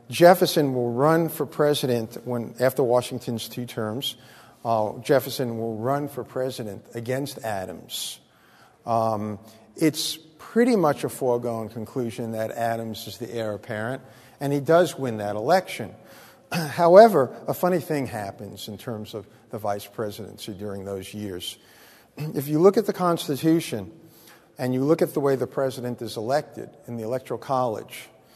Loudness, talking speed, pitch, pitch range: -24 LUFS, 150 wpm, 125 Hz, 110-145 Hz